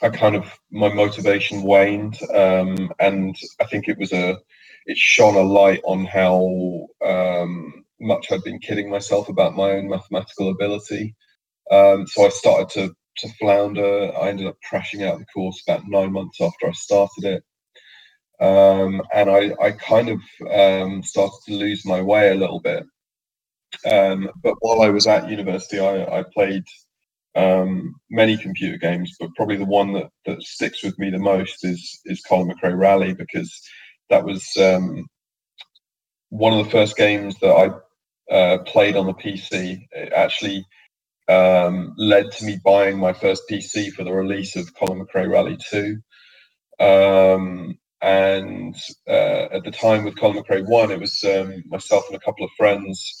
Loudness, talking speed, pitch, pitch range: -19 LUFS, 170 wpm, 100 Hz, 95-100 Hz